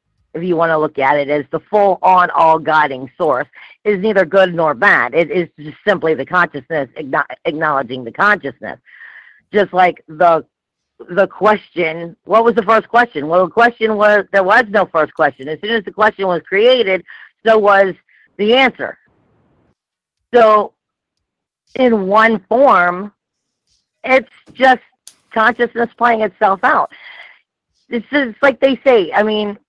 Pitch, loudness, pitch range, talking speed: 195 Hz, -14 LUFS, 165-225 Hz, 150 wpm